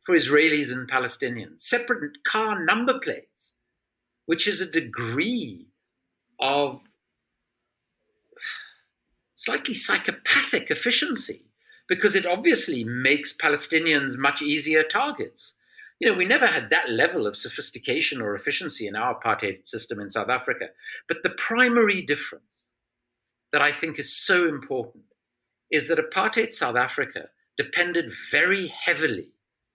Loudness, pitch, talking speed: -23 LUFS, 170 Hz, 120 wpm